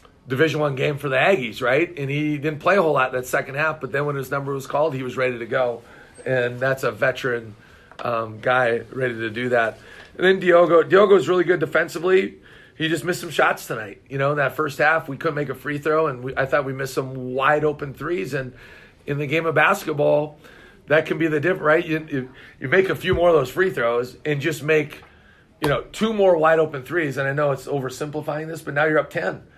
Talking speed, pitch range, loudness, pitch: 240 wpm, 130-160 Hz, -21 LUFS, 145 Hz